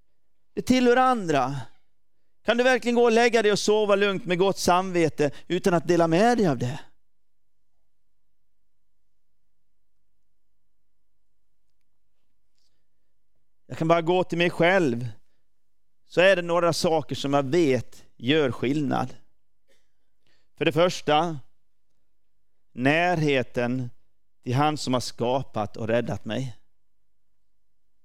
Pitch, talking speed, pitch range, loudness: 160 Hz, 110 wpm, 125-185 Hz, -23 LUFS